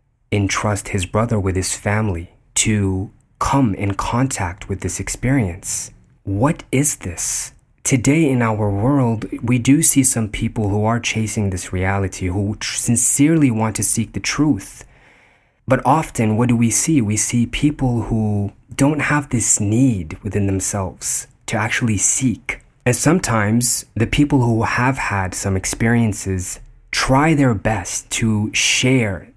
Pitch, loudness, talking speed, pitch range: 115 Hz, -18 LUFS, 145 wpm, 100-130 Hz